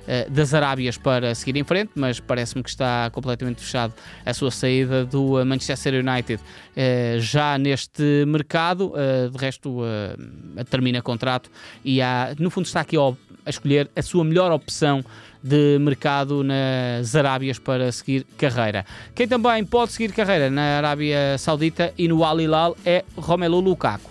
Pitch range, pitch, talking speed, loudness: 125-155 Hz, 135 Hz, 145 wpm, -22 LUFS